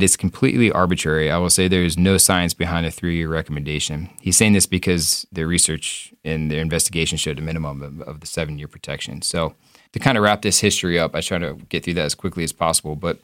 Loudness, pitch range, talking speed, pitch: -19 LUFS, 80-95 Hz, 220 wpm, 85 Hz